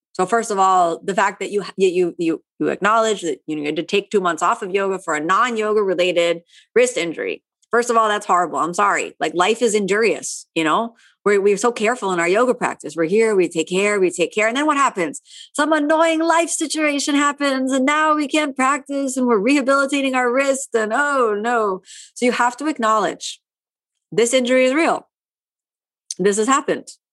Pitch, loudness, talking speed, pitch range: 225 Hz, -18 LUFS, 205 wpm, 195-275 Hz